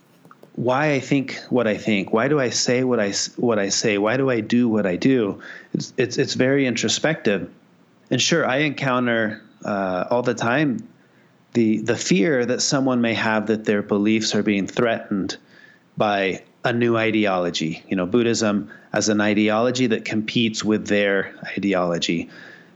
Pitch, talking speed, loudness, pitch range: 110 Hz, 165 wpm, -21 LUFS, 105-125 Hz